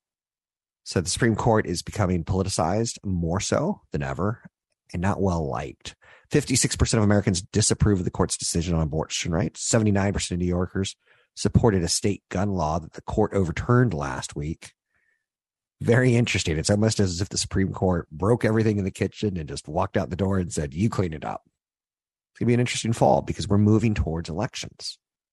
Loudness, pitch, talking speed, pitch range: -24 LUFS, 100 Hz, 185 wpm, 90-110 Hz